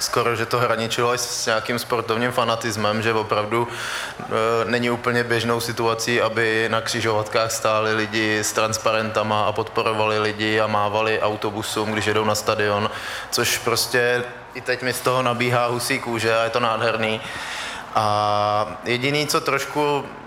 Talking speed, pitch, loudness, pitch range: 150 wpm, 115 Hz, -21 LUFS, 110-120 Hz